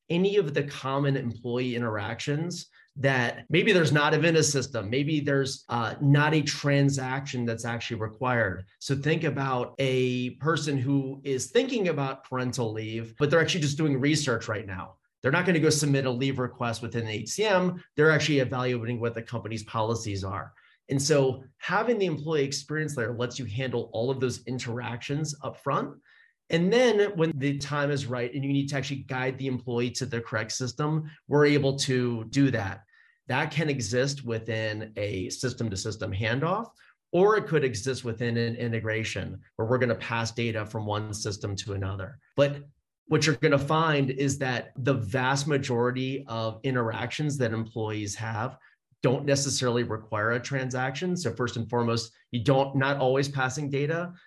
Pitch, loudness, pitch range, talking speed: 130 Hz, -27 LUFS, 115-145 Hz, 175 wpm